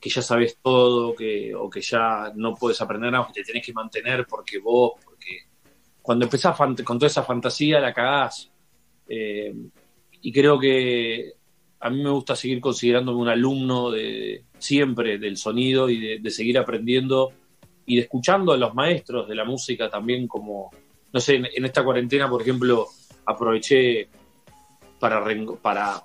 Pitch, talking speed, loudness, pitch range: 125 Hz, 170 wpm, -22 LUFS, 115-130 Hz